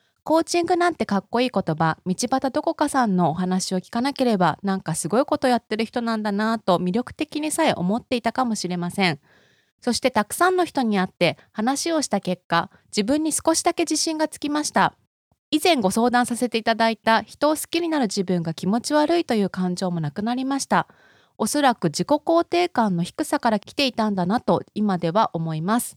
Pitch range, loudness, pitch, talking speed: 185-295 Hz, -22 LUFS, 230 Hz, 400 characters per minute